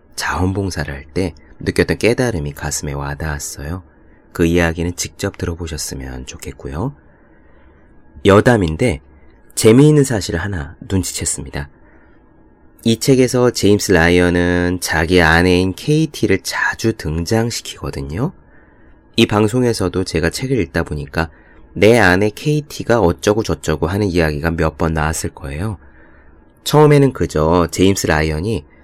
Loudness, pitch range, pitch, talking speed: -16 LUFS, 80-110 Hz, 85 Hz, 290 characters per minute